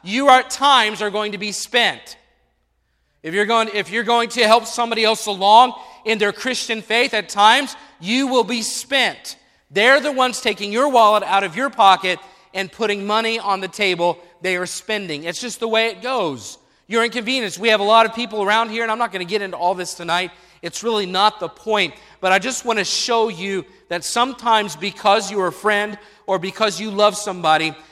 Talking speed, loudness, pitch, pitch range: 210 wpm, -18 LUFS, 210 Hz, 190-230 Hz